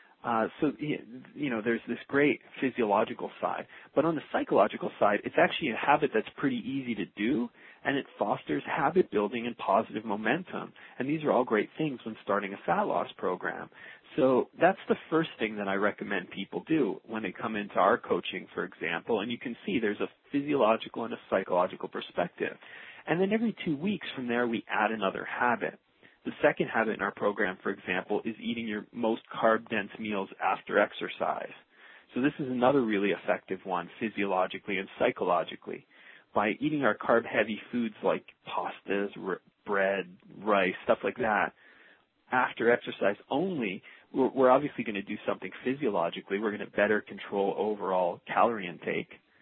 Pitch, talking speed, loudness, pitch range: 110 Hz, 175 wpm, -30 LUFS, 100-135 Hz